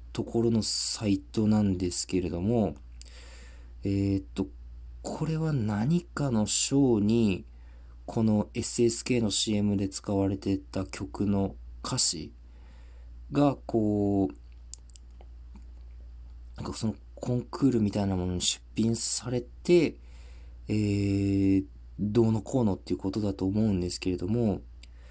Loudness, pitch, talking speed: -28 LUFS, 95 Hz, 225 characters per minute